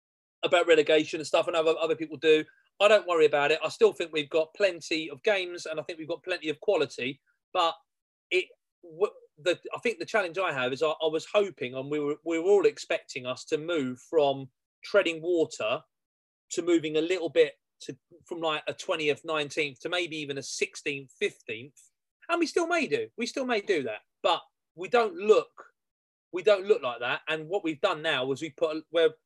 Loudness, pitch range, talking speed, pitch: -28 LUFS, 155-215 Hz, 215 wpm, 165 Hz